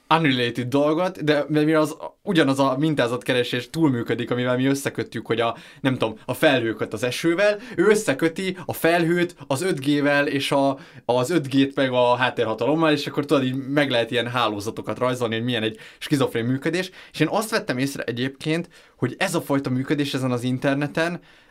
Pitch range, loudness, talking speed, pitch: 125-160 Hz, -22 LUFS, 170 wpm, 140 Hz